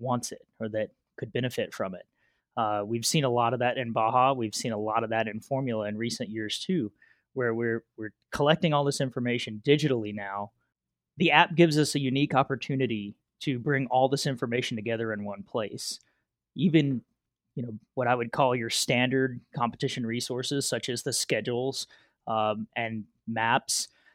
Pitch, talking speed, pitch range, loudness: 120 Hz, 180 wpm, 110-135 Hz, -28 LUFS